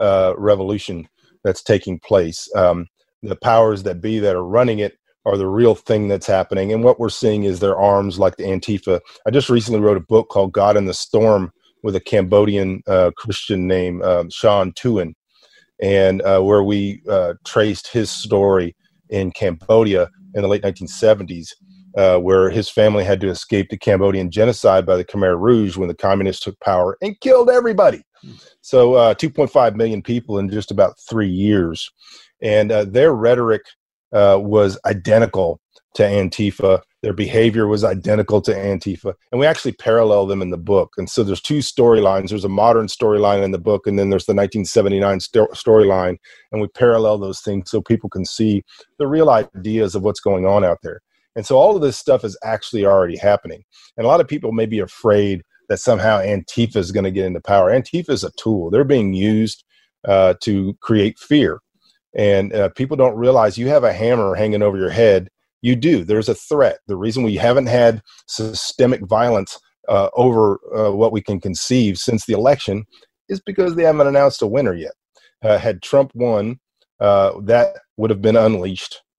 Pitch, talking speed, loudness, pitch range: 105 Hz, 185 wpm, -16 LUFS, 95-115 Hz